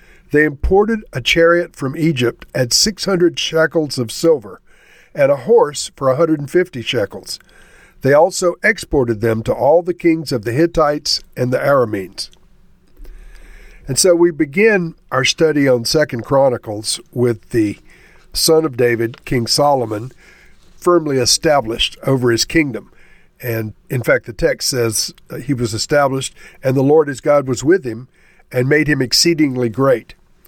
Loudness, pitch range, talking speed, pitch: -15 LUFS, 125-170 Hz, 145 wpm, 145 Hz